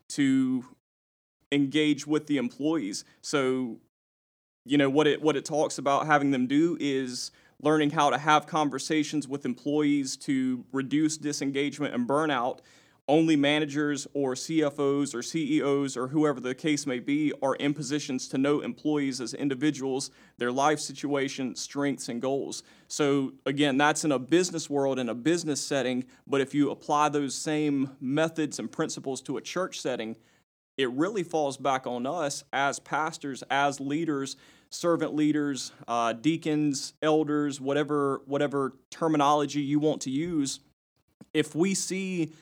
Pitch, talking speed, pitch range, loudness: 145 Hz, 150 wpm, 135-155 Hz, -28 LUFS